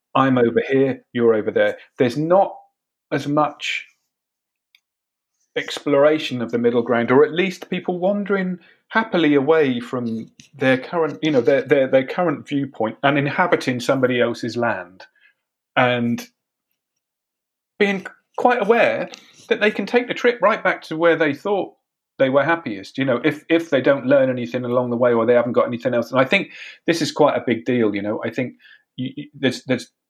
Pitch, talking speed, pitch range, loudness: 140 Hz, 180 wpm, 125-180 Hz, -19 LUFS